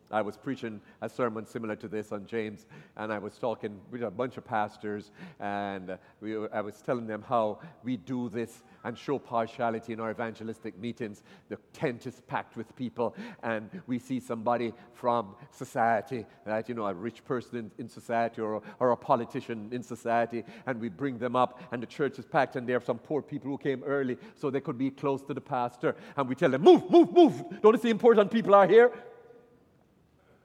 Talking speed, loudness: 210 wpm, -29 LUFS